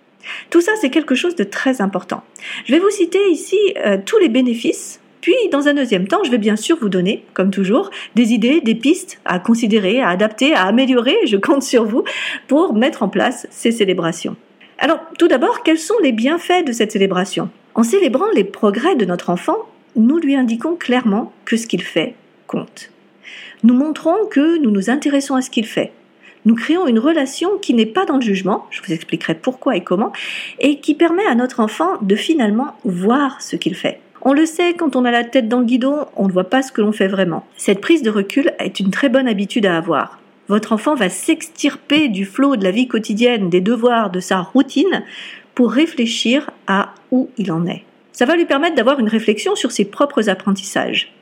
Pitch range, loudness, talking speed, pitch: 205-300 Hz, -16 LUFS, 210 wpm, 250 Hz